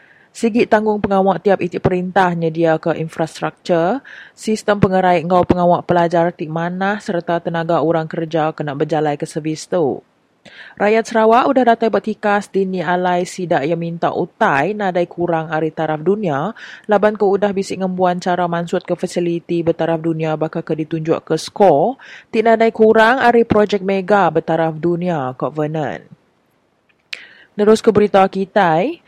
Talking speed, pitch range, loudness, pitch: 145 wpm, 165-205 Hz, -16 LUFS, 180 Hz